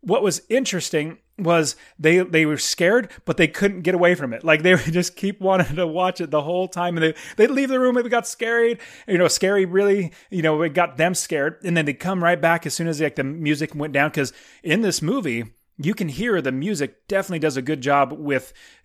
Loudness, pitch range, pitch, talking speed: -21 LUFS, 155-195 Hz, 175 Hz, 245 wpm